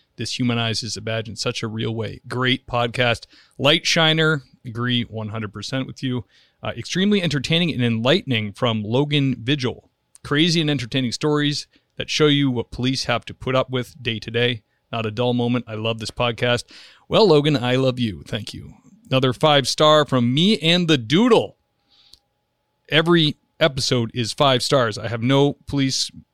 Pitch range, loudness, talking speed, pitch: 115-145 Hz, -20 LUFS, 170 wpm, 125 Hz